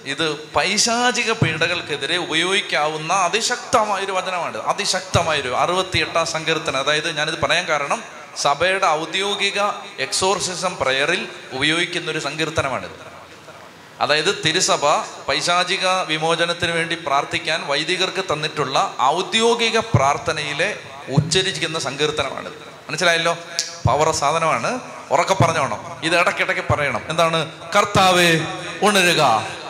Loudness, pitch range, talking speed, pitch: -19 LUFS, 150-185 Hz, 90 wpm, 165 Hz